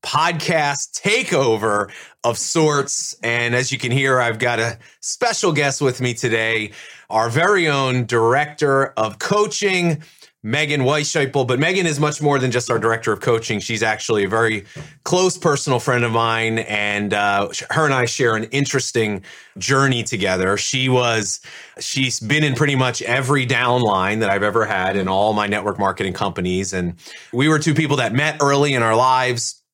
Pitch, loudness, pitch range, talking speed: 125 Hz, -18 LUFS, 110-145 Hz, 170 wpm